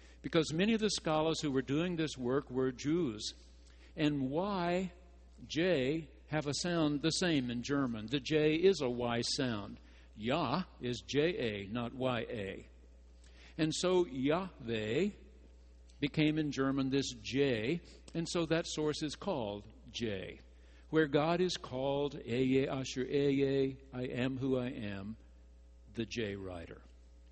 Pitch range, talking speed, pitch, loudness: 105-155 Hz, 140 wpm, 130 Hz, -35 LUFS